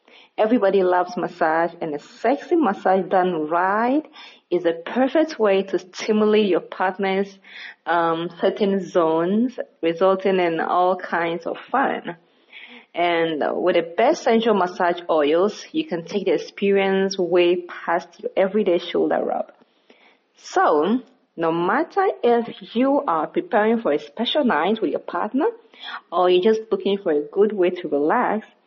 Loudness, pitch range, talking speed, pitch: -21 LUFS, 175-225 Hz, 140 wpm, 195 Hz